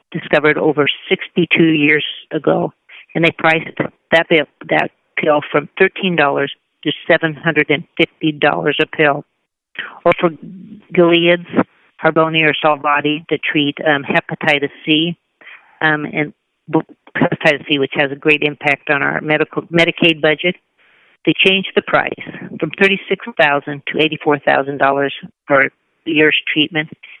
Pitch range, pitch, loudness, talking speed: 150-170 Hz, 155 Hz, -15 LUFS, 115 wpm